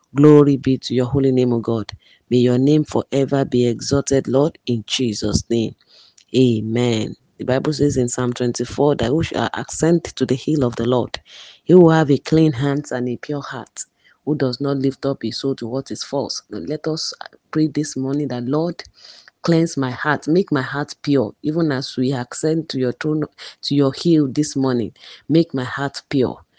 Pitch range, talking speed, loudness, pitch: 125-150 Hz, 195 wpm, -19 LUFS, 135 Hz